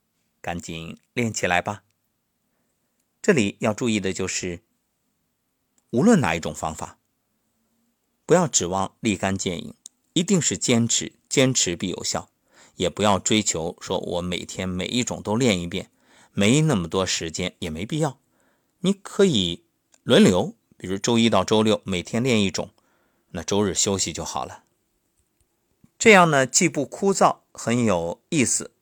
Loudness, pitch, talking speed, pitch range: -22 LUFS, 105 Hz, 210 characters per minute, 90-125 Hz